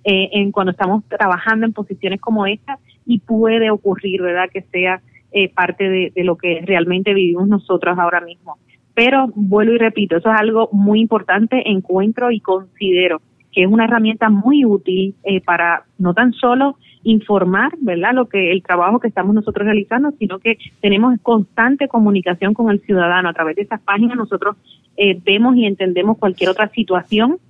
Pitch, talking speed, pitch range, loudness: 200 Hz, 170 wpm, 185-225 Hz, -15 LUFS